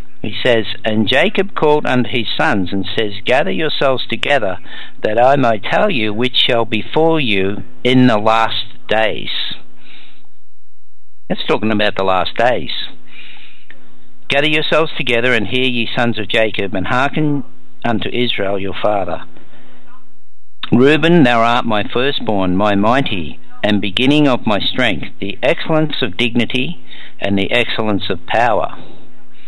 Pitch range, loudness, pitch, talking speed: 105-130 Hz, -15 LUFS, 120 Hz, 140 wpm